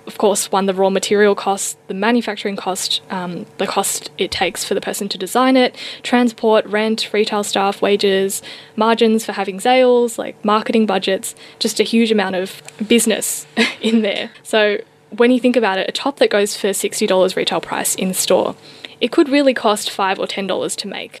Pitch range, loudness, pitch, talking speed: 195-235 Hz, -17 LUFS, 210 Hz, 185 wpm